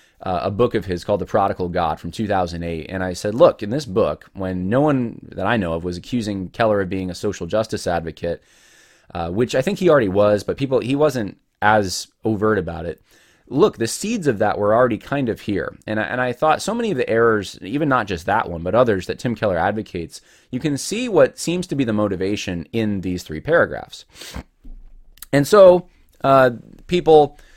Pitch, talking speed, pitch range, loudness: 110 Hz, 210 wpm, 95-135 Hz, -19 LUFS